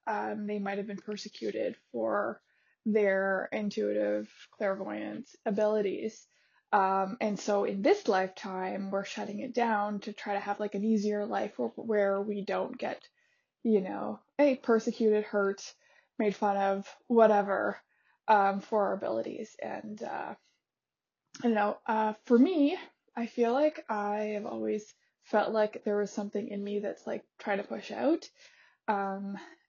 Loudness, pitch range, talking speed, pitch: -31 LUFS, 200-225 Hz, 150 wpm, 210 Hz